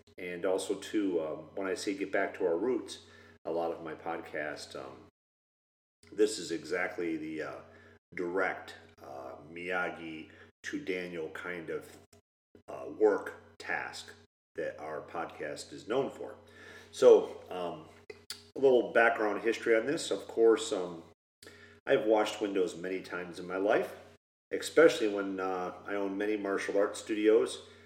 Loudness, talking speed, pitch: -32 LUFS, 145 wpm, 105 Hz